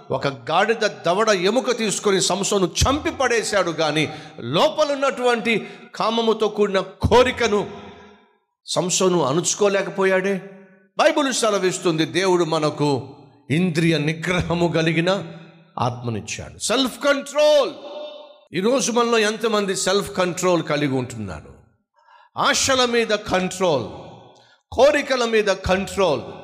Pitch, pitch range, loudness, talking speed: 190 Hz, 175-235 Hz, -20 LUFS, 85 wpm